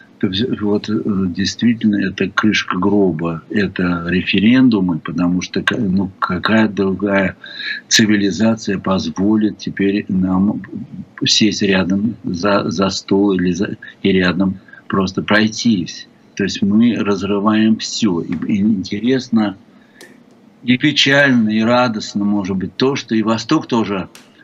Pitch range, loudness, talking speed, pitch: 95-115 Hz, -16 LUFS, 110 wpm, 105 Hz